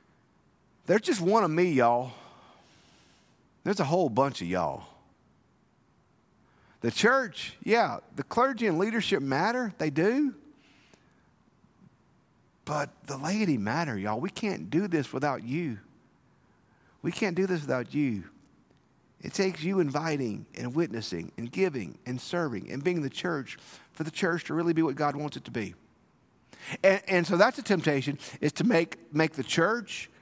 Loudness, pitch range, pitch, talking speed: -29 LUFS, 135-190 Hz, 165 Hz, 155 wpm